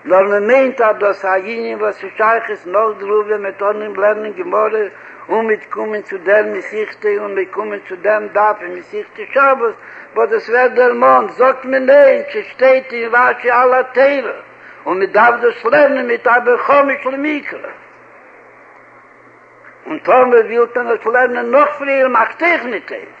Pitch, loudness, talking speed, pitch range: 230 Hz, -14 LUFS, 165 wpm, 210-265 Hz